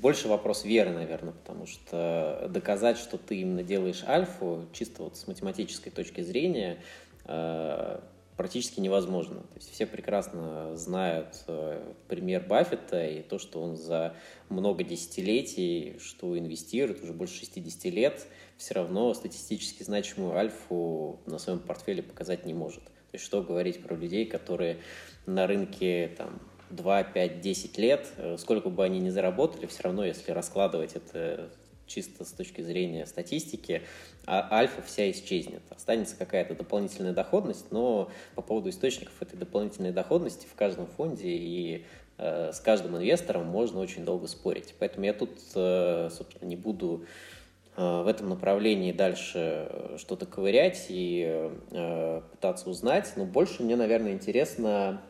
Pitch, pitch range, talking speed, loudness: 90 Hz, 85-100 Hz, 135 wpm, -31 LUFS